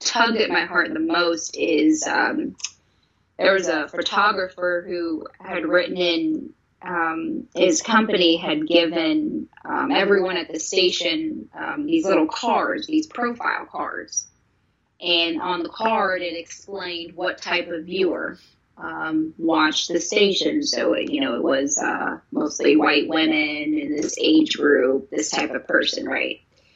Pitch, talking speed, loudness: 185 Hz, 150 wpm, -21 LUFS